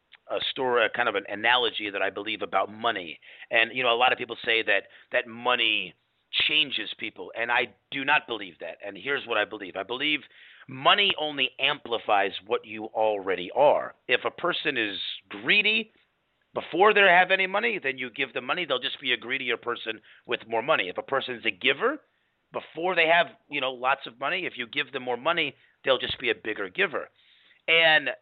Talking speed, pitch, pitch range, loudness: 205 wpm, 135 Hz, 115-165 Hz, -25 LUFS